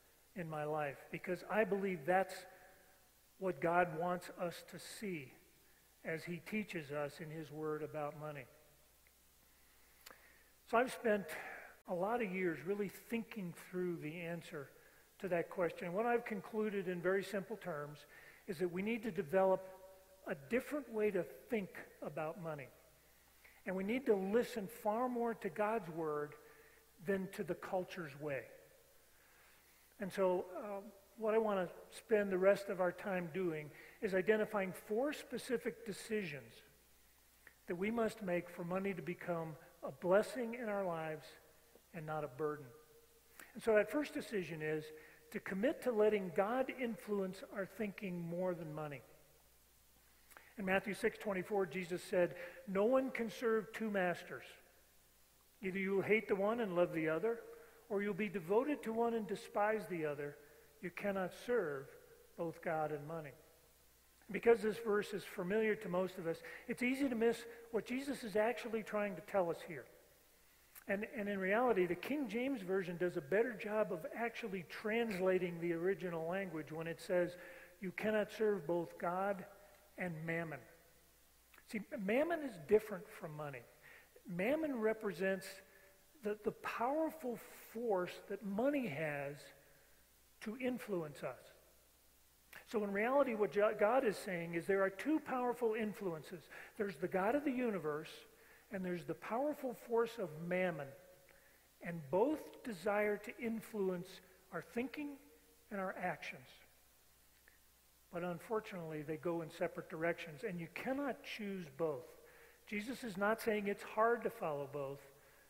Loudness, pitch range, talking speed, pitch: -40 LUFS, 170-220 Hz, 150 wpm, 190 Hz